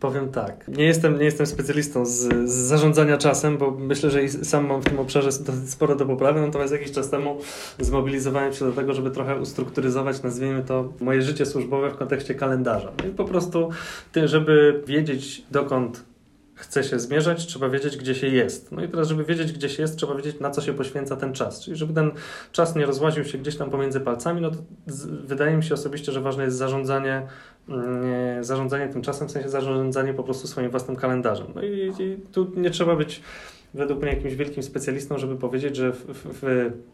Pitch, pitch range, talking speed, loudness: 140 Hz, 130-150 Hz, 205 wpm, -24 LUFS